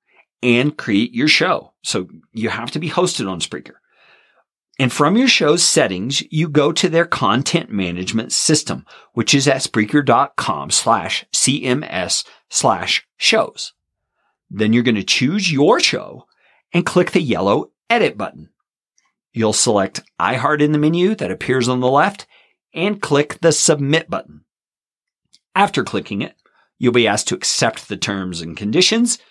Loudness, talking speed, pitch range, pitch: -17 LUFS, 150 wpm, 120-165 Hz, 145 Hz